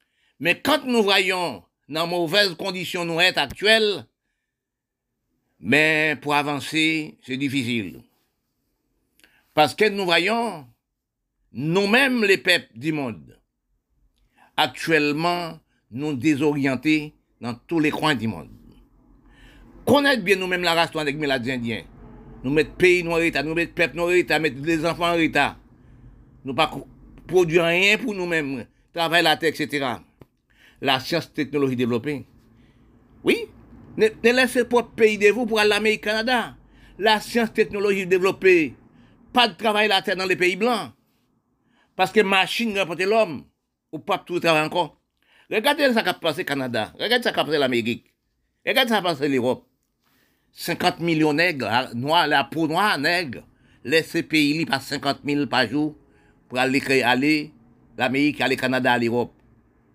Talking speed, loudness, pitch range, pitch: 150 wpm, -21 LUFS, 130-190 Hz, 155 Hz